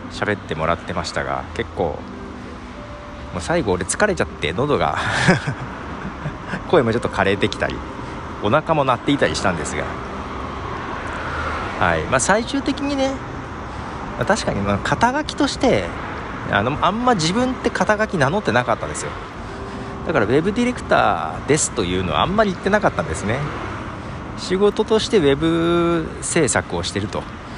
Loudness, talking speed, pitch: -20 LUFS, 320 characters per minute, 115 Hz